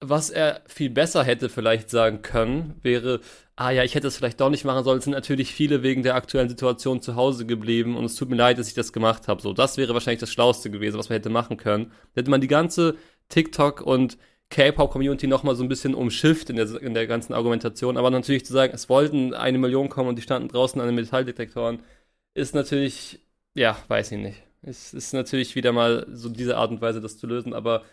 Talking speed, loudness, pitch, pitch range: 230 wpm, -23 LUFS, 125 Hz, 115-135 Hz